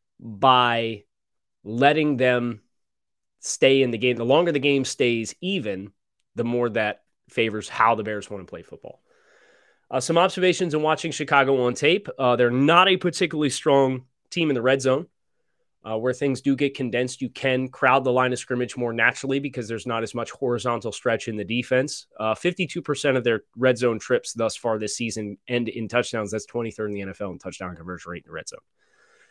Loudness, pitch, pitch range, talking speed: -23 LUFS, 125 Hz, 110-135 Hz, 195 wpm